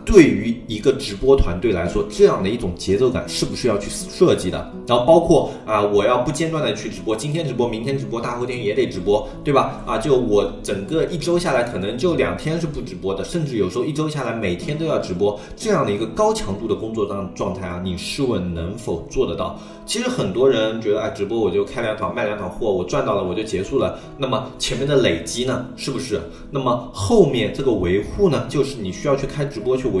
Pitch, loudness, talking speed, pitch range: 120 Hz, -20 LUFS, 350 characters per minute, 100-145 Hz